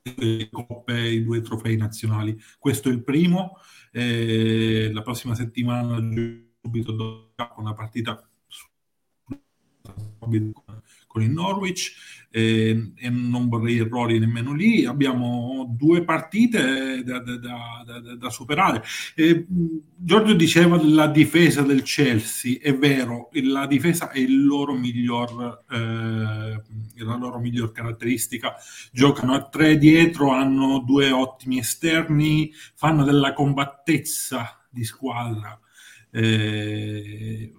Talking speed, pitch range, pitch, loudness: 115 wpm, 115-140 Hz, 120 Hz, -21 LUFS